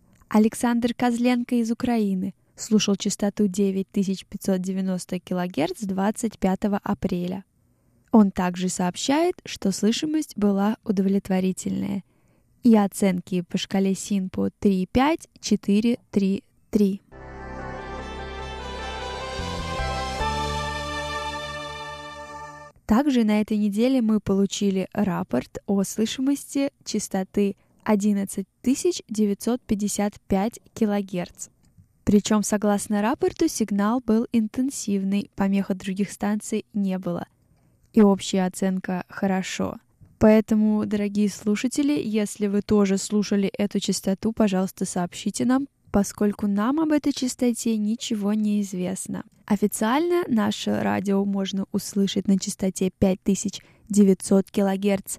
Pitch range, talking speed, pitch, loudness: 190-220 Hz, 90 wpm, 205 Hz, -24 LUFS